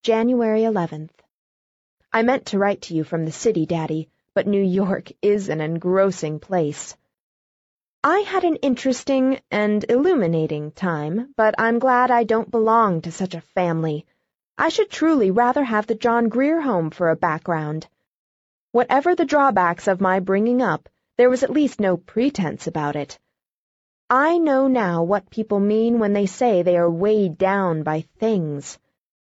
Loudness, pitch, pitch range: -20 LUFS, 205 Hz, 170-245 Hz